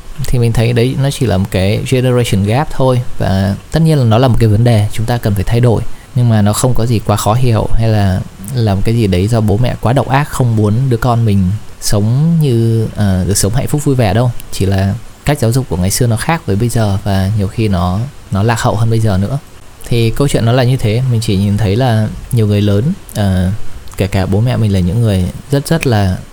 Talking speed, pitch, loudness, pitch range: 260 wpm, 115 Hz, -13 LUFS, 100-125 Hz